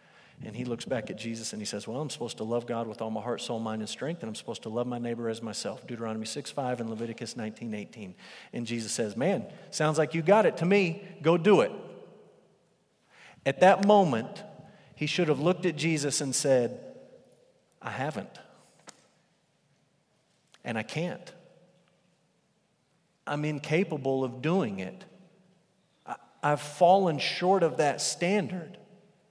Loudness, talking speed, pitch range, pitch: -29 LUFS, 165 wpm, 120-185 Hz, 155 Hz